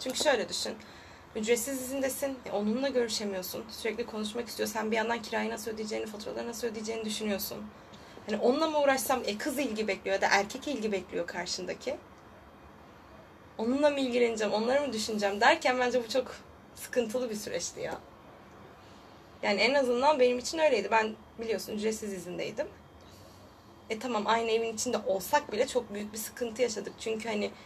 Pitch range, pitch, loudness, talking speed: 210-250 Hz, 225 Hz, -31 LUFS, 160 wpm